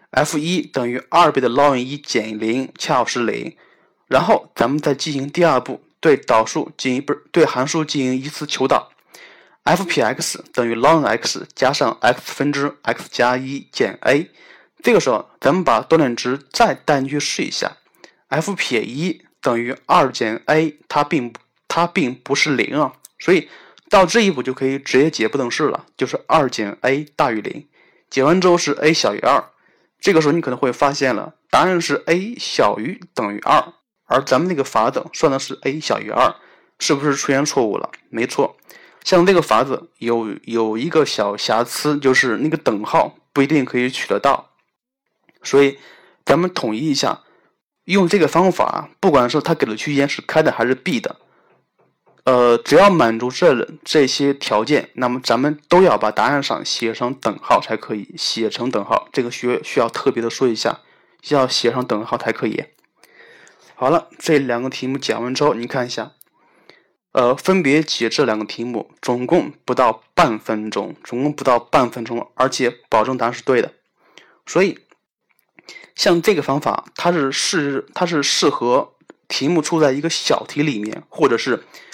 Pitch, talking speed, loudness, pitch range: 135 Hz, 255 characters per minute, -18 LUFS, 120-155 Hz